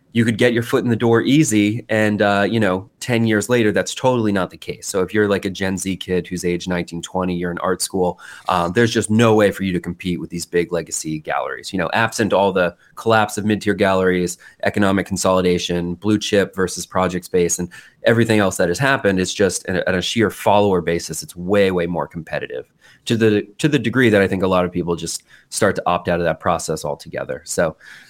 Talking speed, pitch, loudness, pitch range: 230 wpm, 95 Hz, -19 LUFS, 90-110 Hz